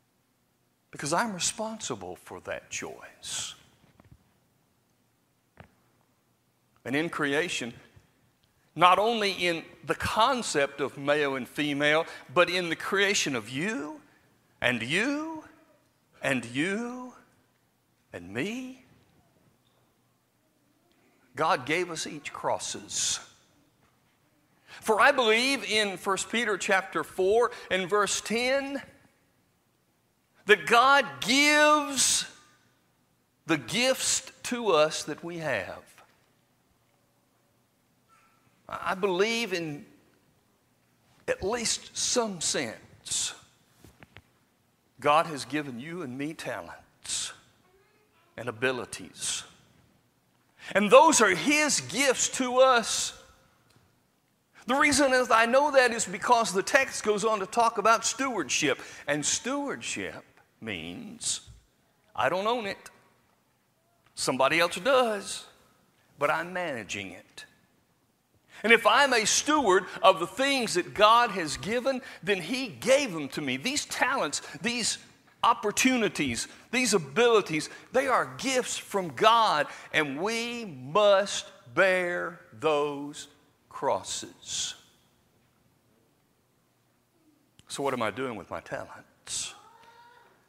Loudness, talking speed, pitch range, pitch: -26 LUFS, 100 wpm, 165-255 Hz, 210 Hz